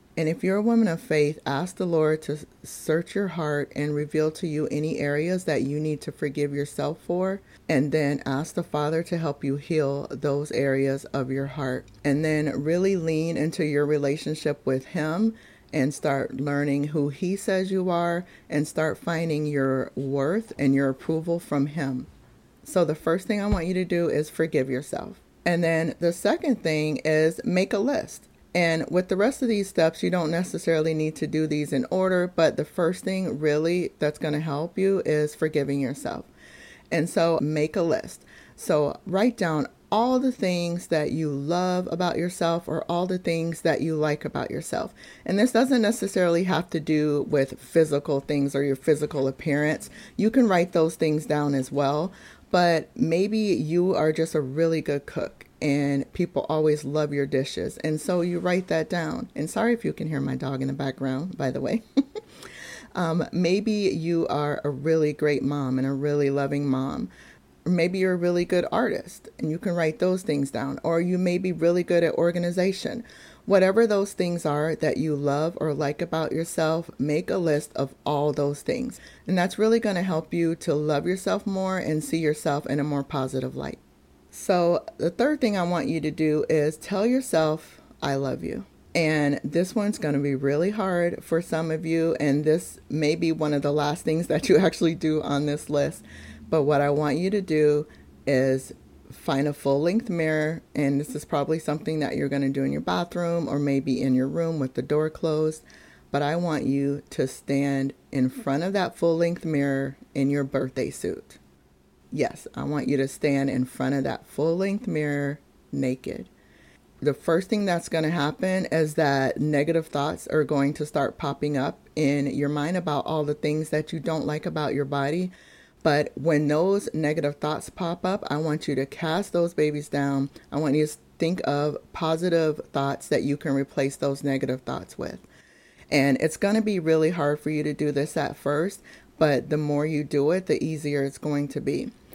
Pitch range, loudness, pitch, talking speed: 145-170 Hz, -25 LUFS, 155 Hz, 195 wpm